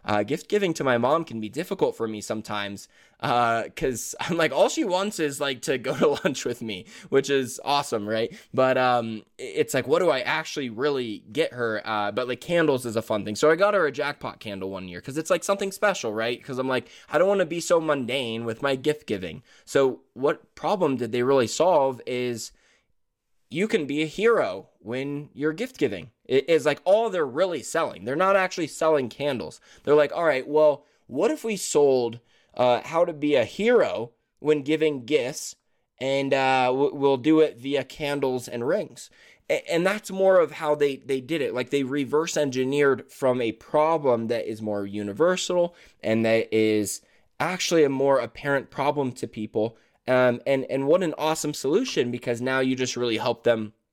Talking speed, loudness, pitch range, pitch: 200 wpm, -25 LUFS, 120-155 Hz, 140 Hz